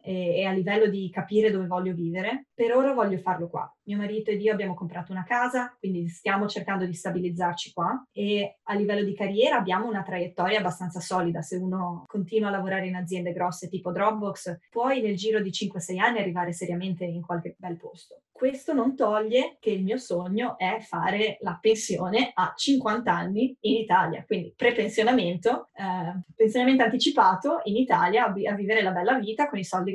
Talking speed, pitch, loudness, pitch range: 180 wpm, 205 Hz, -26 LUFS, 185-225 Hz